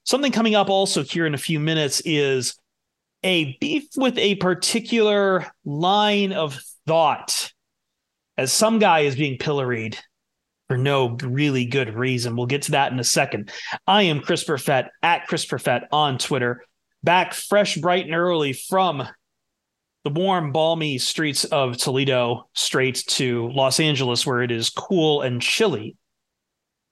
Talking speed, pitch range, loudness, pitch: 150 wpm, 130-185 Hz, -21 LUFS, 150 Hz